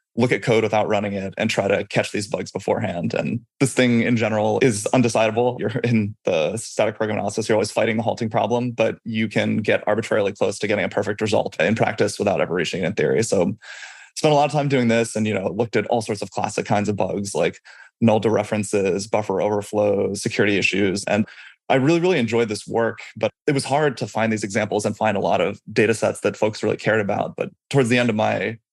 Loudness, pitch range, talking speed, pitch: -21 LUFS, 105-120 Hz, 235 wpm, 110 Hz